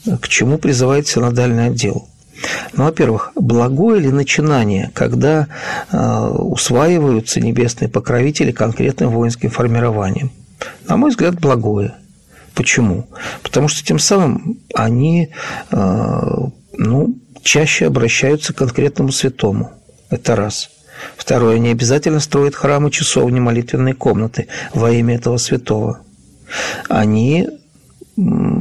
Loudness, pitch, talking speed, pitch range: -15 LUFS, 135 Hz, 105 wpm, 120-155 Hz